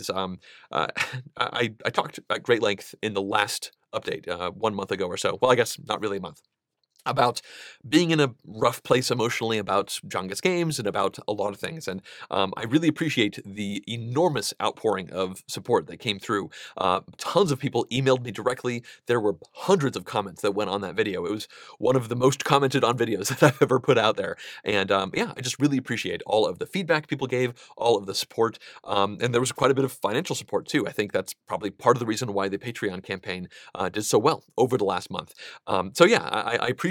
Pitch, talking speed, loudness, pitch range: 120 Hz, 230 wpm, -25 LUFS, 105-135 Hz